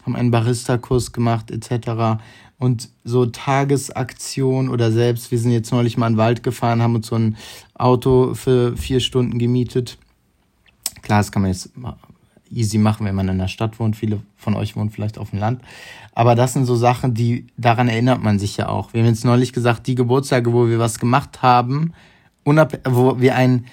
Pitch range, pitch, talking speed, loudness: 115-125 Hz, 120 Hz, 195 wpm, -18 LUFS